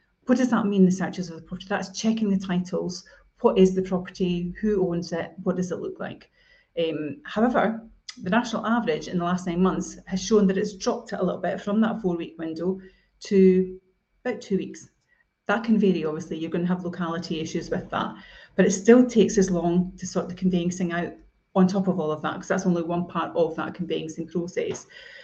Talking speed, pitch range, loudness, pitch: 215 wpm, 175-205 Hz, -25 LUFS, 185 Hz